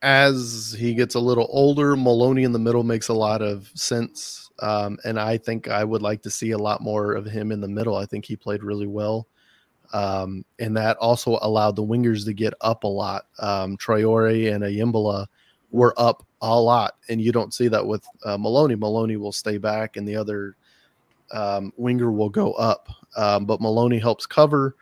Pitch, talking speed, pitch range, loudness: 110 Hz, 200 wpm, 105-120 Hz, -22 LUFS